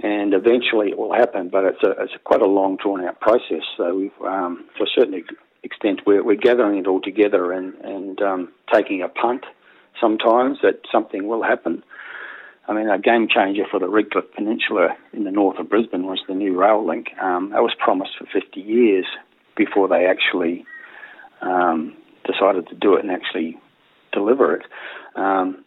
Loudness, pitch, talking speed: -19 LUFS, 105 Hz, 185 wpm